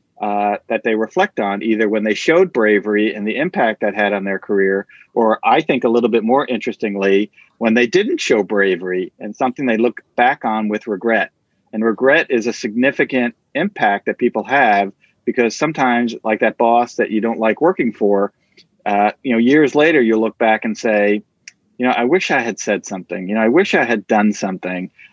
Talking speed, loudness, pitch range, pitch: 205 wpm, -16 LUFS, 105-120 Hz, 110 Hz